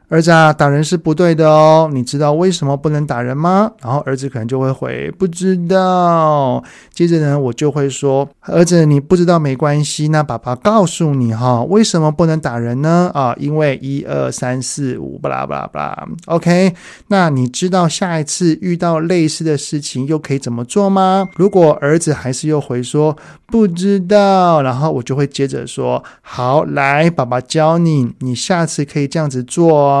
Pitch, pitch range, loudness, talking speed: 150 Hz, 135-170 Hz, -14 LUFS, 275 characters per minute